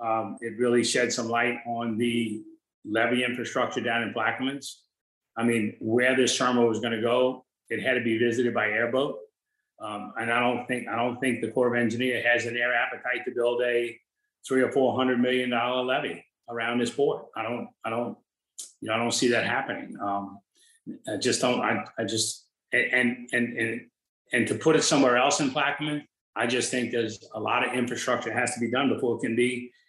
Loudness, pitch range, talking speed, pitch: -26 LUFS, 115-125 Hz, 210 wpm, 120 Hz